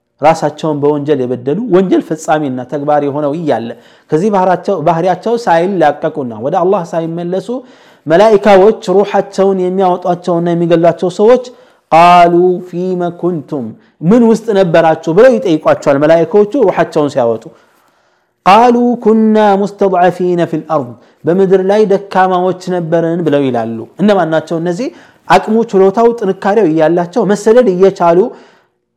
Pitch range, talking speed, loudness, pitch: 160-200 Hz, 95 wpm, -11 LUFS, 175 Hz